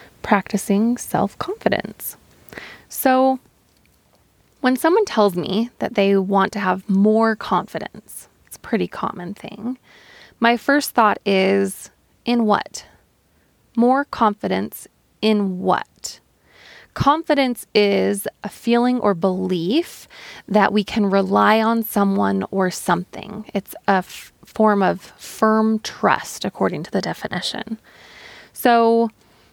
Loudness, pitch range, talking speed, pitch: -19 LUFS, 195-235 Hz, 115 wpm, 210 Hz